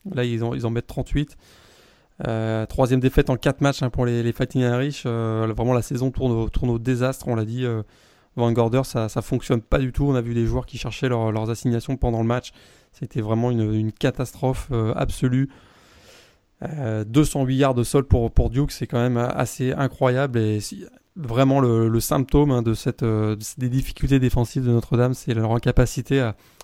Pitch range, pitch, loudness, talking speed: 115-130 Hz, 125 Hz, -22 LUFS, 205 wpm